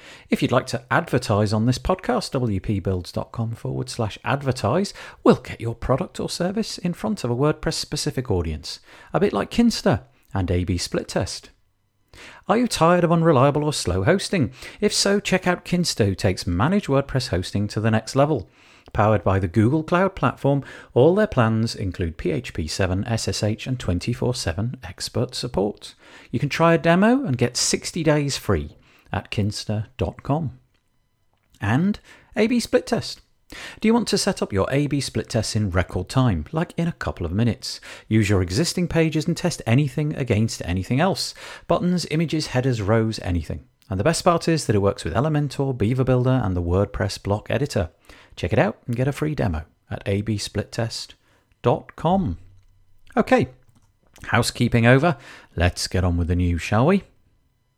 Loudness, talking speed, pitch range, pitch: -22 LUFS, 165 wpm, 100-150 Hz, 120 Hz